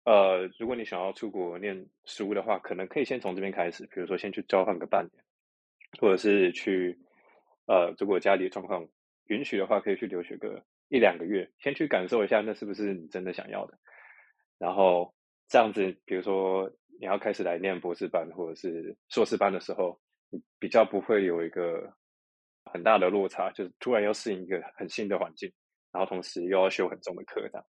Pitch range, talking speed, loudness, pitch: 85-95 Hz, 300 characters per minute, -29 LUFS, 95 Hz